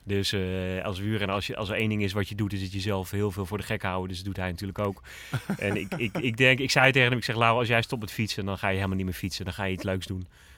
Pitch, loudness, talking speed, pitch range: 100 Hz, -27 LUFS, 340 wpm, 95-110 Hz